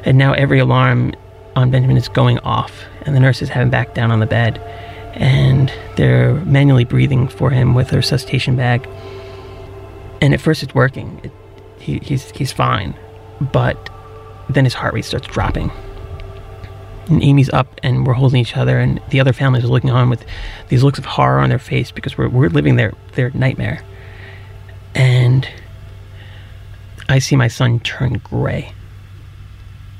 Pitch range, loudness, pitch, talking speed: 100-130 Hz, -15 LUFS, 120 Hz, 165 wpm